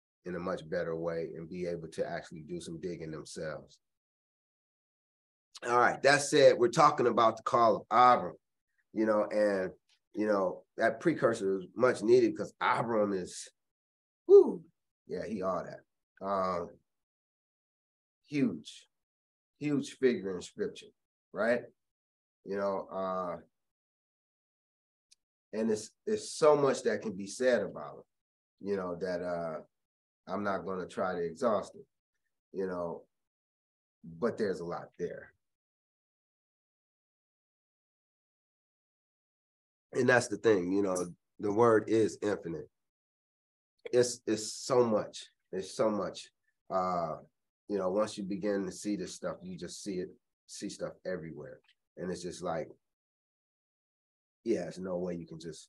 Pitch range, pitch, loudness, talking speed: 85-125 Hz, 100 Hz, -31 LUFS, 135 wpm